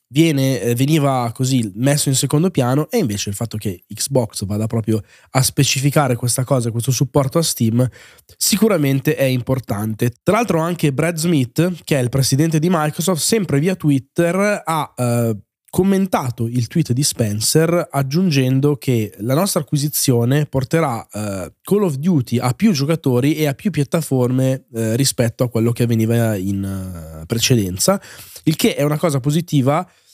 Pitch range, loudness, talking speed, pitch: 120-160 Hz, -18 LUFS, 155 wpm, 135 Hz